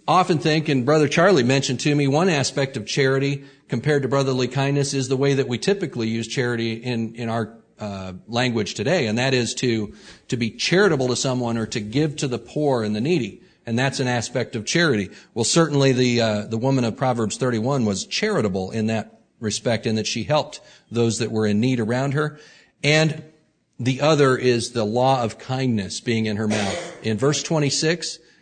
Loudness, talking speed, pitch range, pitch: -21 LUFS, 205 wpm, 115-140 Hz, 125 Hz